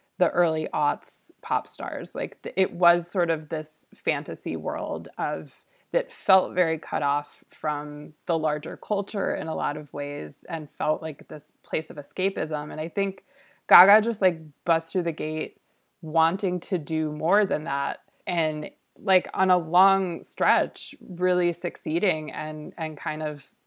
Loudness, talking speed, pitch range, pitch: -26 LUFS, 160 wpm, 155-190 Hz, 165 Hz